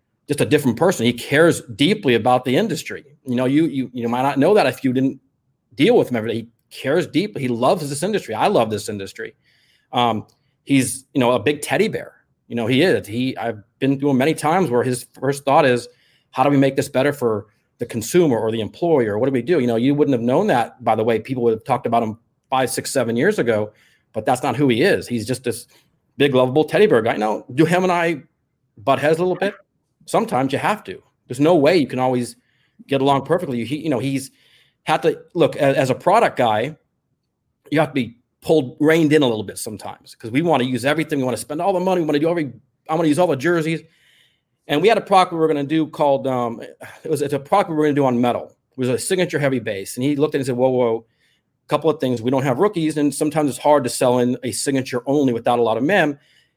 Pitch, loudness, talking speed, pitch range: 135 Hz, -19 LUFS, 260 wpm, 125-155 Hz